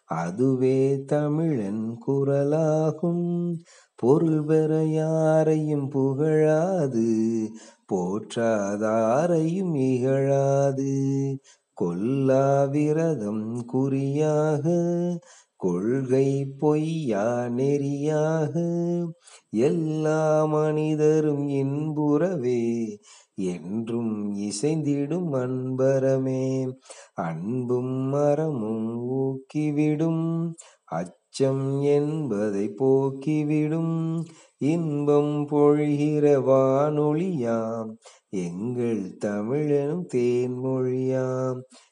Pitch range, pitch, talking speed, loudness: 125-155 Hz, 140 Hz, 45 wpm, -24 LUFS